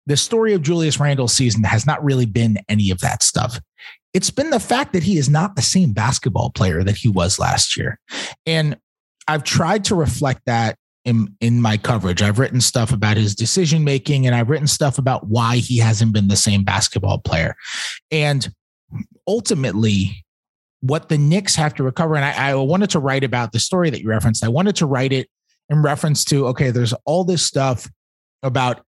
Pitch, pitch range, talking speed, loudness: 130 Hz, 110-155 Hz, 195 wpm, -18 LUFS